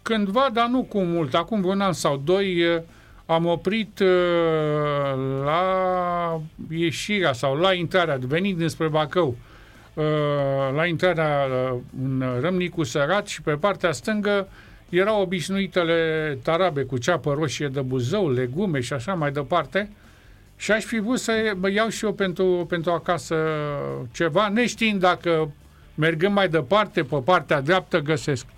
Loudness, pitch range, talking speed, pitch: -23 LUFS, 145-190 Hz, 135 wpm, 170 Hz